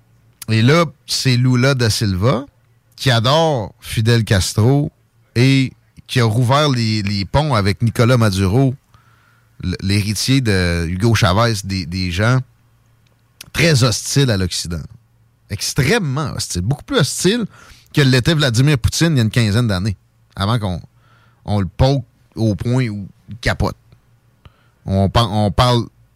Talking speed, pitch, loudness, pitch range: 140 wpm, 120 Hz, -16 LUFS, 105-130 Hz